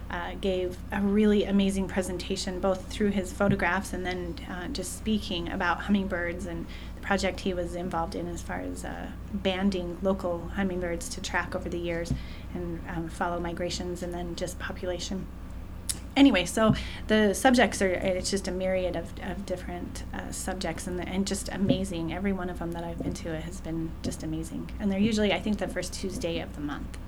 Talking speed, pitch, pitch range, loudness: 195 wpm, 180 Hz, 165-195 Hz, -29 LUFS